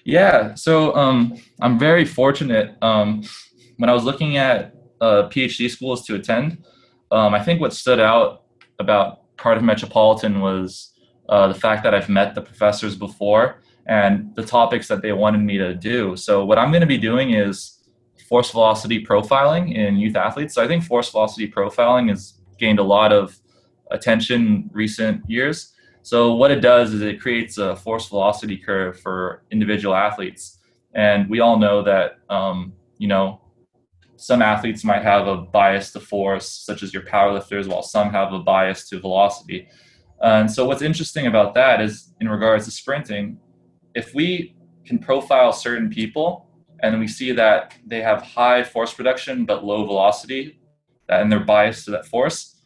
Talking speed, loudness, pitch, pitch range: 170 wpm, -18 LUFS, 110 Hz, 100-125 Hz